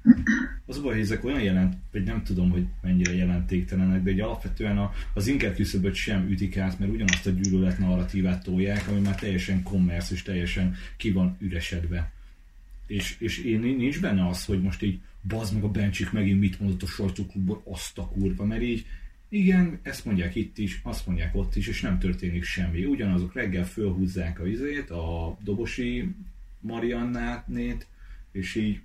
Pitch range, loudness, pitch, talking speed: 90-105 Hz, -27 LUFS, 95 Hz, 175 wpm